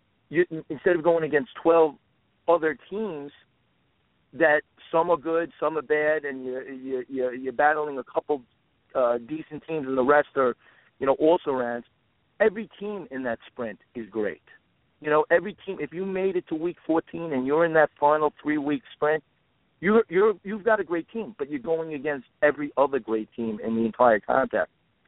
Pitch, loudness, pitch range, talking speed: 150 Hz, -25 LUFS, 130-170 Hz, 185 wpm